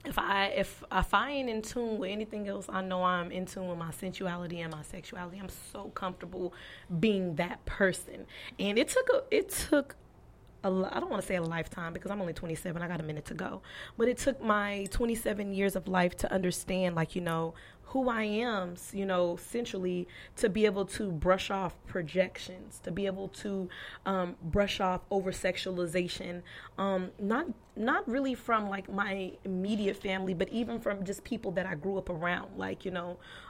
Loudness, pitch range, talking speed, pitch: -33 LUFS, 180-205 Hz, 195 wpm, 190 Hz